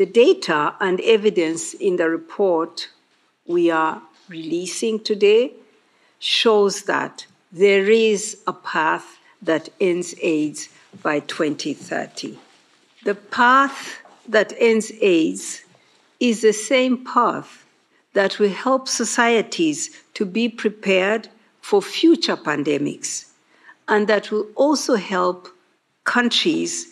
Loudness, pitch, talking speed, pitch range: -19 LUFS, 215 Hz, 105 wpm, 185-255 Hz